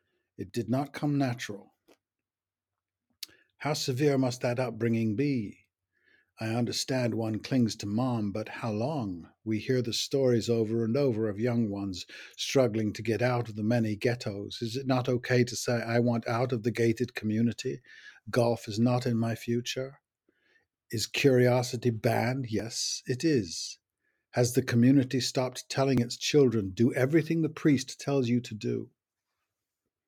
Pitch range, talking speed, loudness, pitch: 110-130 Hz, 155 wpm, -29 LUFS, 120 Hz